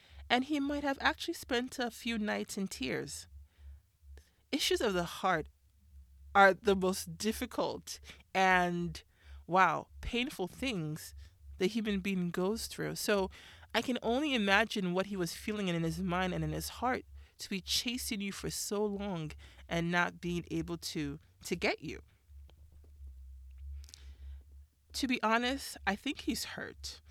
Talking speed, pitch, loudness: 145 wpm, 180 Hz, -34 LUFS